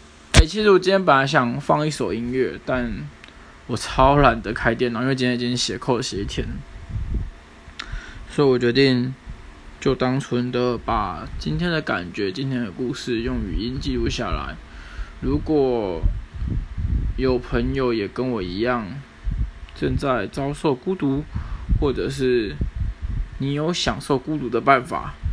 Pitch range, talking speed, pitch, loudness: 95-135 Hz, 210 characters per minute, 125 Hz, -22 LUFS